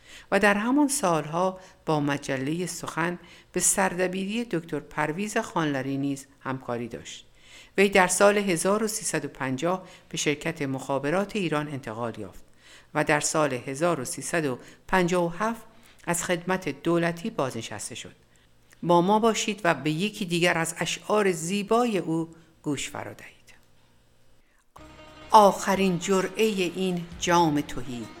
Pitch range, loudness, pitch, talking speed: 140-190 Hz, -26 LUFS, 170 Hz, 115 wpm